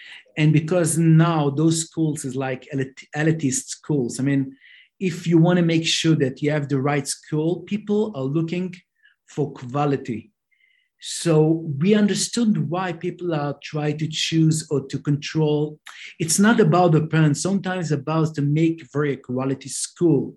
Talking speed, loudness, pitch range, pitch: 155 wpm, -21 LUFS, 145-175 Hz, 155 Hz